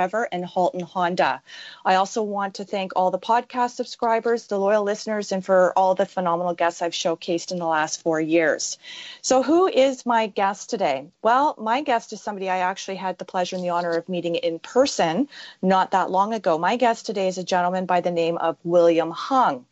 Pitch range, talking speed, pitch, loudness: 180-230 Hz, 205 wpm, 190 Hz, -22 LUFS